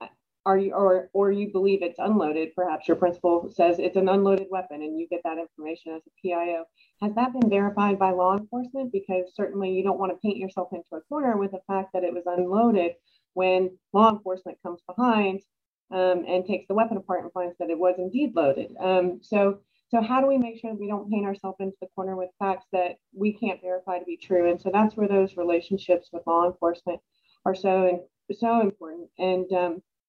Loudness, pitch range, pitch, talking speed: -25 LUFS, 175-200 Hz, 185 Hz, 215 wpm